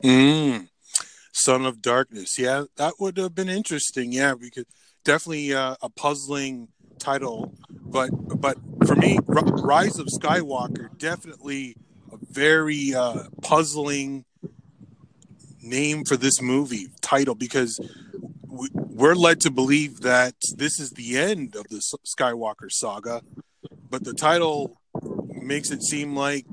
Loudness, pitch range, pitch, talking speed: -23 LUFS, 130-150 Hz, 140 Hz, 130 wpm